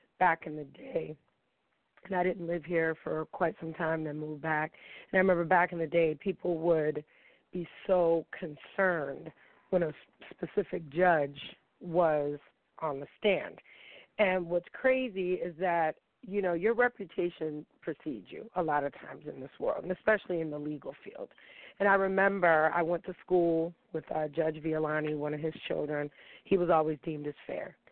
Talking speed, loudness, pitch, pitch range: 175 wpm, -31 LUFS, 170 Hz, 155-185 Hz